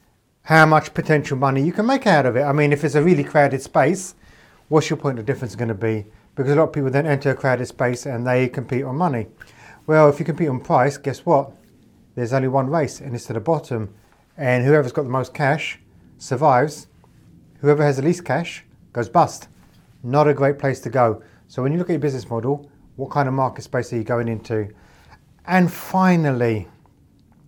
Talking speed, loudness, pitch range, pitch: 215 wpm, -20 LUFS, 125-150 Hz, 140 Hz